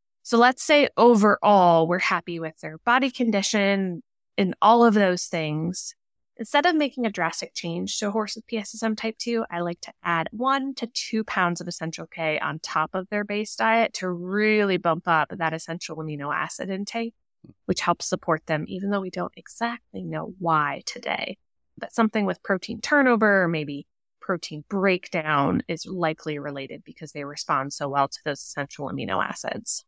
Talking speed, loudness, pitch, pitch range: 175 wpm, -24 LUFS, 185 Hz, 165-225 Hz